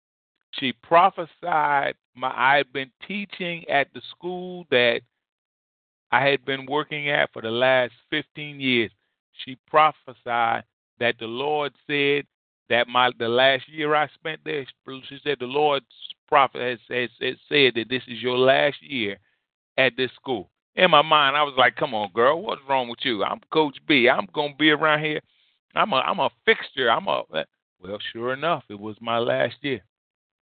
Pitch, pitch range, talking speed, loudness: 135 Hz, 120-150 Hz, 175 wpm, -22 LUFS